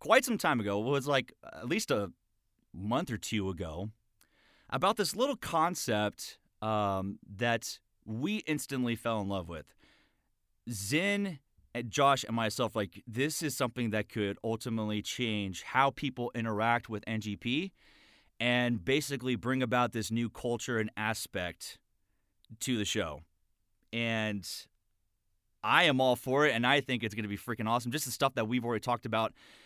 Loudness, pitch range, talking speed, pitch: -32 LUFS, 105-130 Hz, 160 wpm, 115 Hz